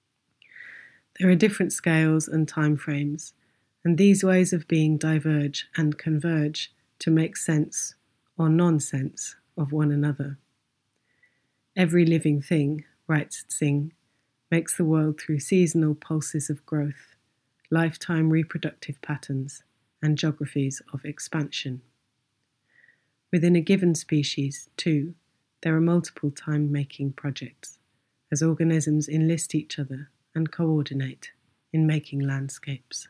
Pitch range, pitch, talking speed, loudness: 140-160 Hz, 155 Hz, 115 wpm, -25 LUFS